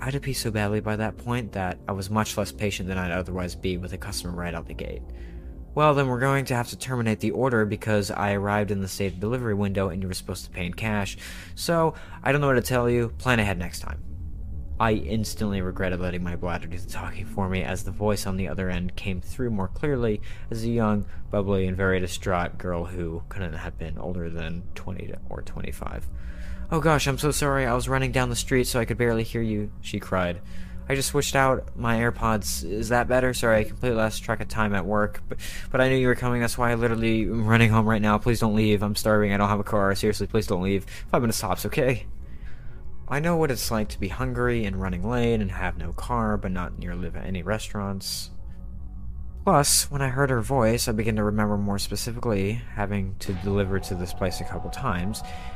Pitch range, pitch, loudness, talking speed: 90-115 Hz, 105 Hz, -26 LUFS, 230 wpm